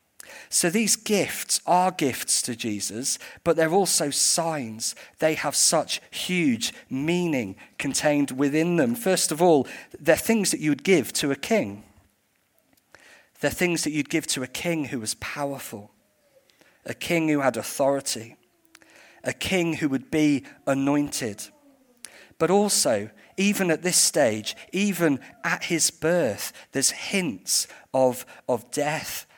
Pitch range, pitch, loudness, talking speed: 130-180 Hz, 155 Hz, -24 LUFS, 140 wpm